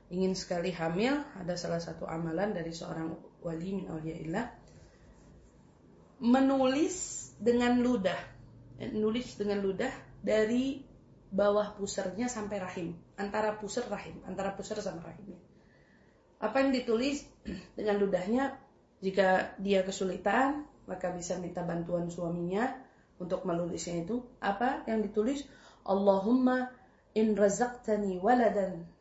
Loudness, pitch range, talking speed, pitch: -32 LUFS, 180-245 Hz, 110 wpm, 200 Hz